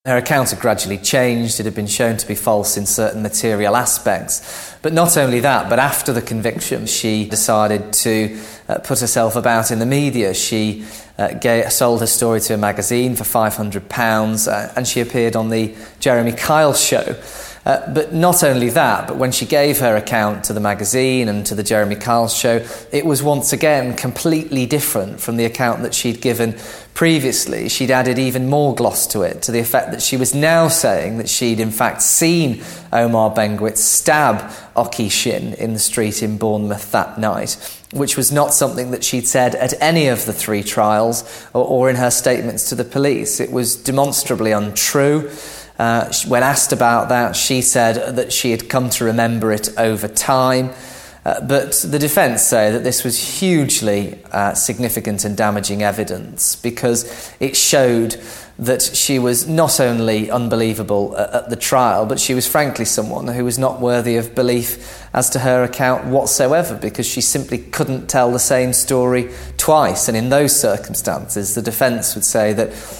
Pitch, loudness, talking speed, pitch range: 120 Hz, -16 LUFS, 180 wpm, 110-130 Hz